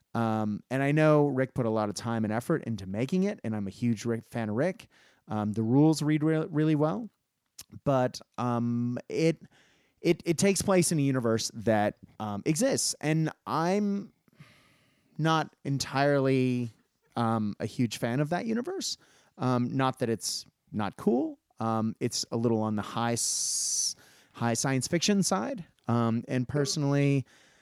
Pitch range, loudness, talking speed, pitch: 115-155 Hz, -29 LUFS, 165 wpm, 130 Hz